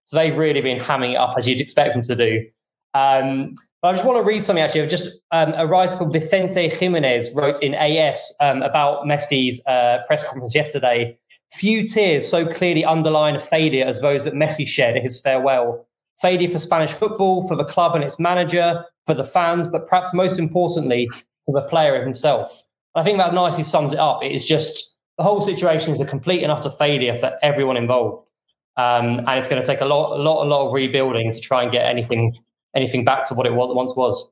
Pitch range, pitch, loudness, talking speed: 130-170 Hz, 150 Hz, -19 LUFS, 215 wpm